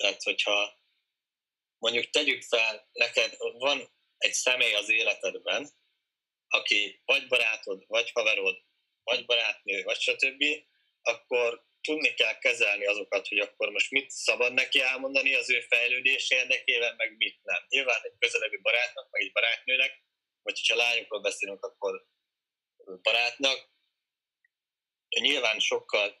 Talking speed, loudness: 125 wpm, -26 LUFS